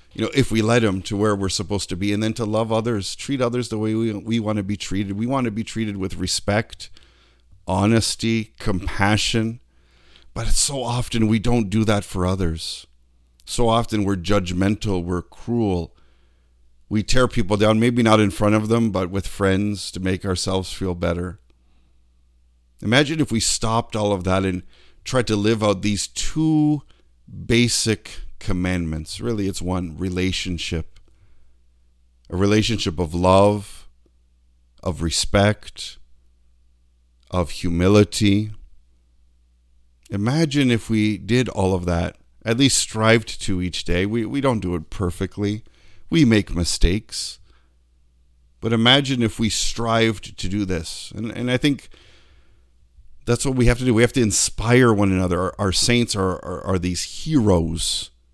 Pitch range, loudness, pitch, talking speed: 80-110 Hz, -21 LUFS, 100 Hz, 155 wpm